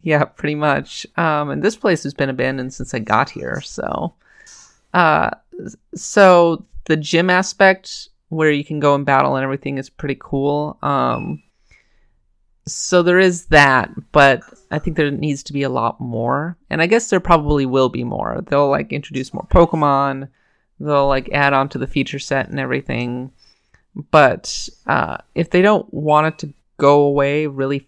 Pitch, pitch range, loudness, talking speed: 145 Hz, 135-165 Hz, -17 LUFS, 170 wpm